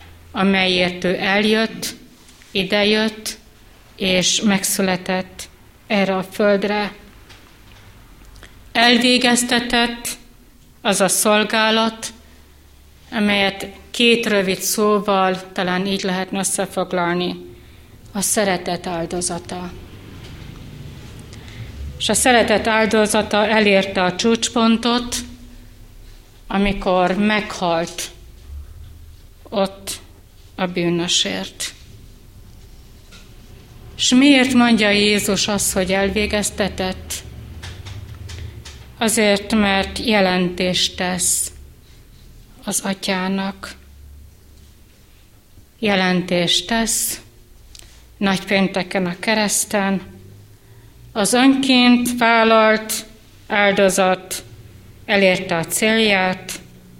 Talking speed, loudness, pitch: 65 wpm, -17 LUFS, 190 Hz